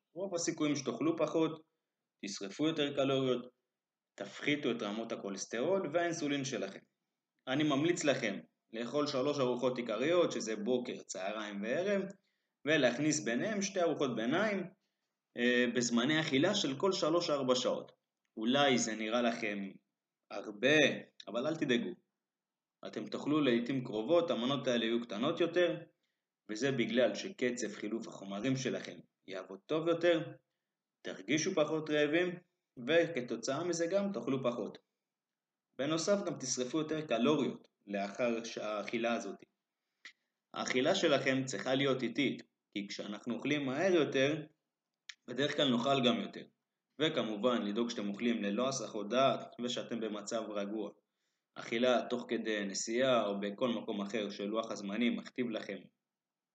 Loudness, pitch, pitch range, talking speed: -34 LUFS, 125 Hz, 115-160 Hz, 120 wpm